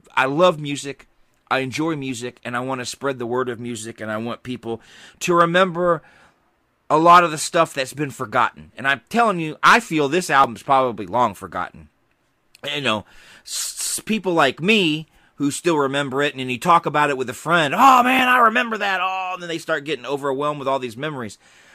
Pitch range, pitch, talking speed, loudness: 125-170 Hz, 145 Hz, 200 wpm, -19 LUFS